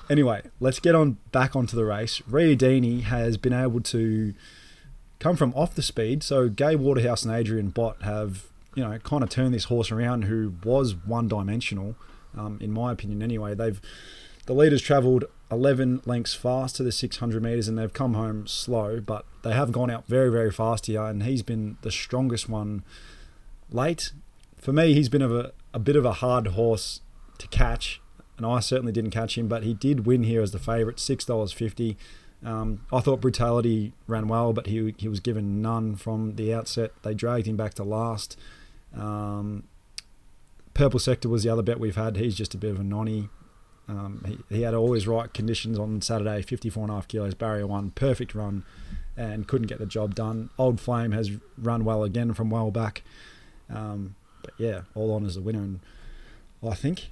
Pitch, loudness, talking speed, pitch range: 115 Hz, -26 LUFS, 190 wpm, 105-125 Hz